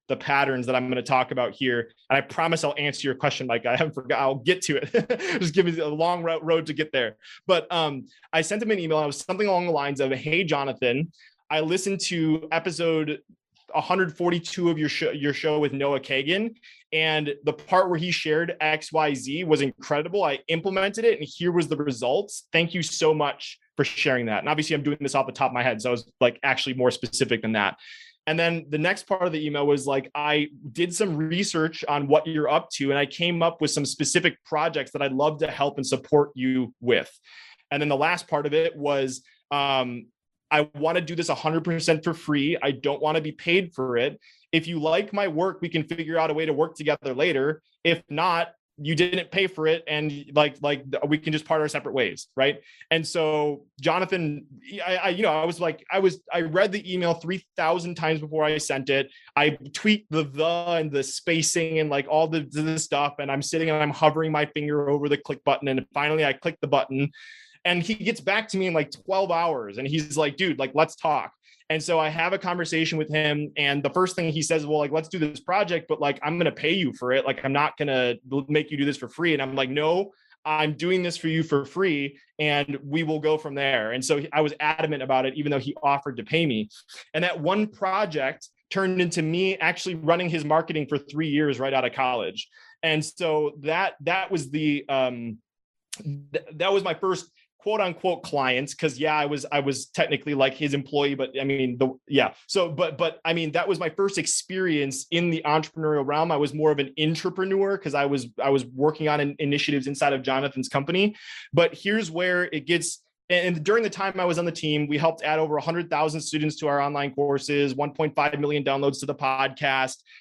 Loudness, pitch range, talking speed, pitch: -25 LUFS, 140-170 Hz, 225 wpm, 155 Hz